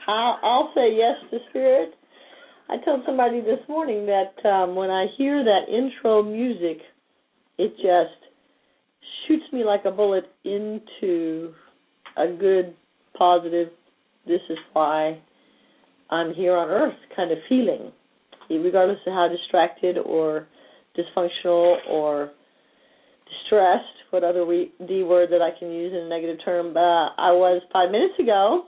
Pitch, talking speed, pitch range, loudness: 180 Hz, 140 wpm, 170-215 Hz, -22 LUFS